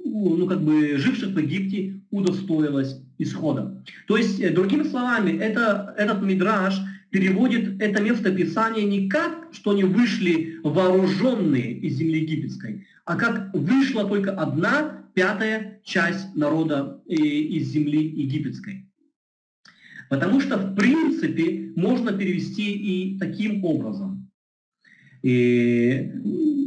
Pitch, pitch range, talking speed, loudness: 195 Hz, 165-215 Hz, 110 wpm, -23 LUFS